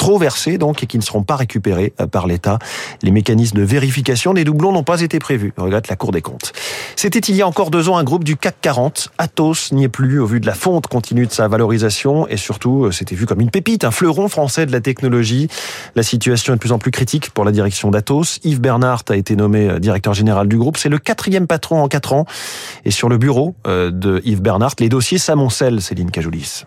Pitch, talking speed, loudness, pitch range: 125 Hz, 235 wpm, -15 LUFS, 105-155 Hz